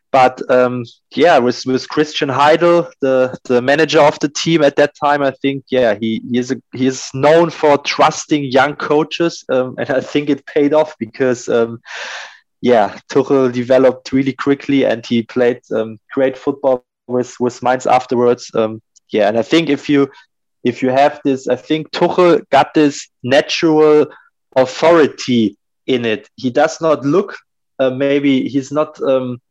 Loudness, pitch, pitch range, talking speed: -15 LUFS, 135 Hz, 125-150 Hz, 170 wpm